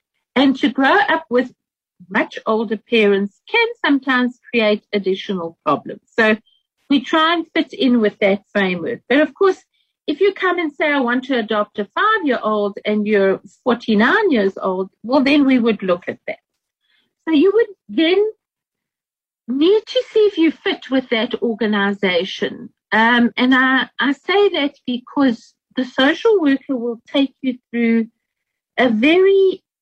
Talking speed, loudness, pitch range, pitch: 160 wpm, -17 LUFS, 220-320 Hz, 255 Hz